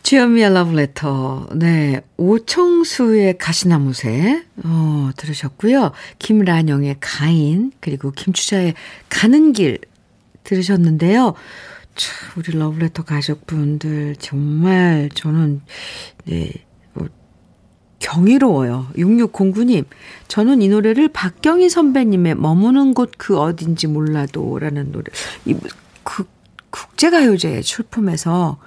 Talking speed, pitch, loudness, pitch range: 225 characters per minute, 170 Hz, -16 LUFS, 150-220 Hz